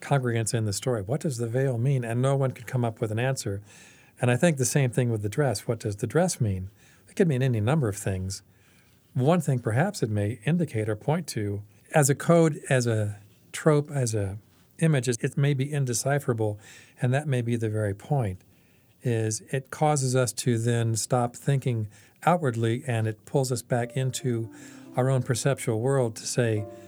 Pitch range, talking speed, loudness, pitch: 110-135 Hz, 200 wpm, -26 LUFS, 125 Hz